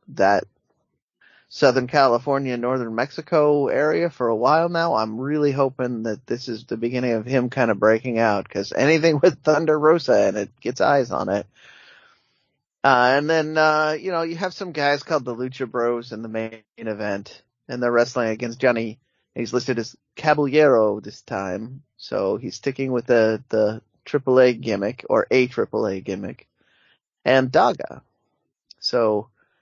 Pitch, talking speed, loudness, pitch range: 125 Hz, 165 wpm, -21 LUFS, 115-145 Hz